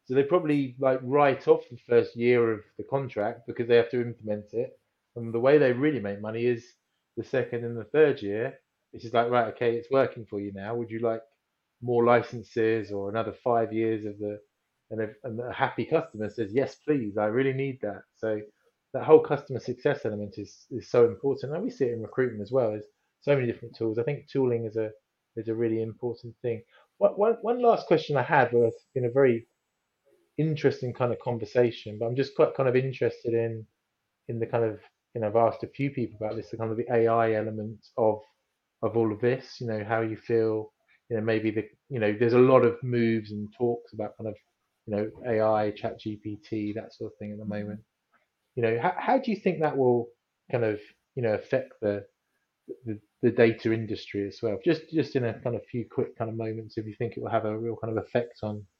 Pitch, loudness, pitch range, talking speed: 115 Hz, -27 LUFS, 110-125 Hz, 225 wpm